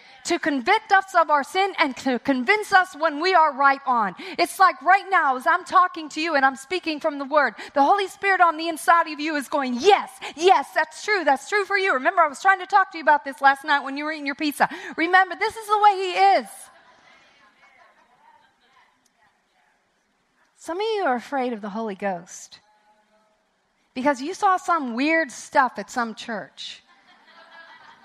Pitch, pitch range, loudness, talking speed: 320 Hz, 275-375 Hz, -21 LUFS, 195 wpm